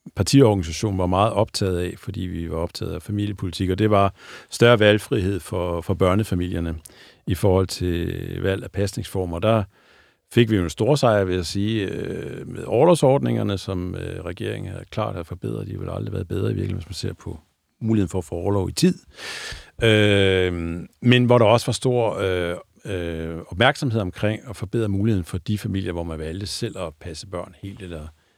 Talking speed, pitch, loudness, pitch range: 185 wpm, 100 Hz, -22 LUFS, 90-110 Hz